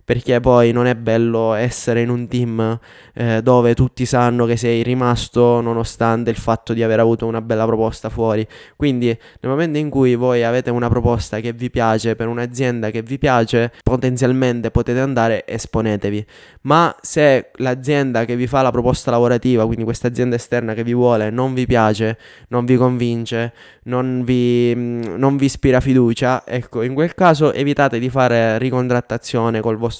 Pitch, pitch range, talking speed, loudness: 120 Hz, 115-125 Hz, 170 wpm, -17 LUFS